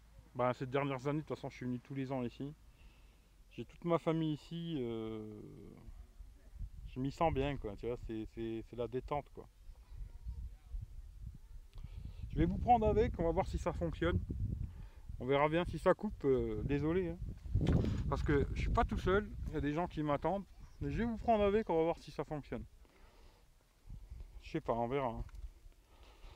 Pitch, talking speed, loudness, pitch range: 125 Hz, 195 wpm, -37 LUFS, 100-155 Hz